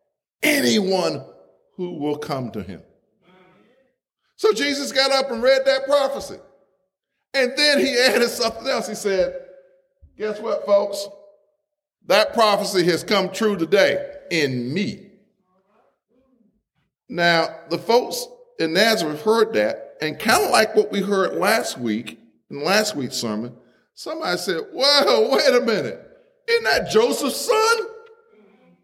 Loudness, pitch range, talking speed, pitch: -20 LUFS, 180-270 Hz, 130 wpm, 205 Hz